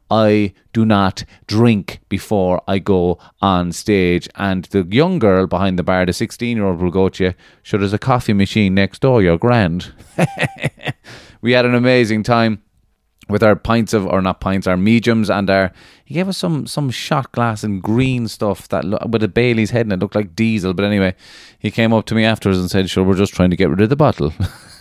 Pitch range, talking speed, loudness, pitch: 95-115 Hz, 220 wpm, -16 LUFS, 105 Hz